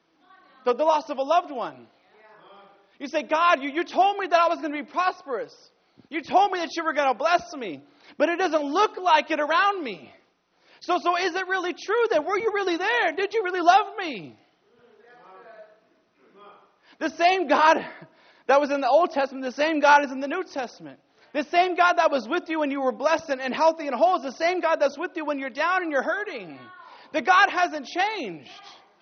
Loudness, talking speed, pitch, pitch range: -23 LUFS, 215 wpm, 330 Hz, 290-365 Hz